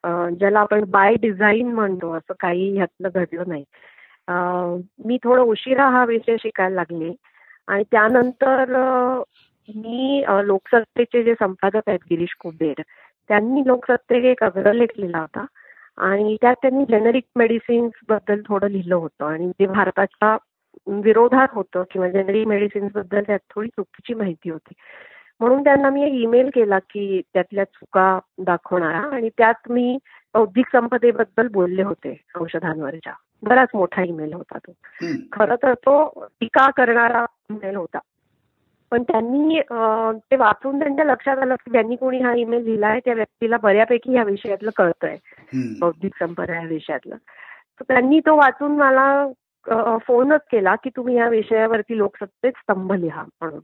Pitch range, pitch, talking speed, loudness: 190-245 Hz, 220 Hz, 140 wpm, -19 LUFS